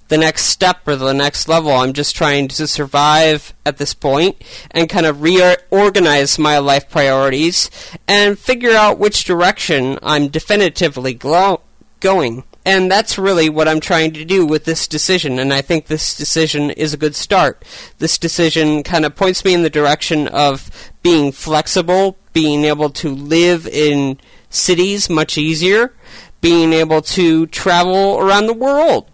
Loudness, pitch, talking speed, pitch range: -13 LUFS, 160 Hz, 160 wpm, 150-185 Hz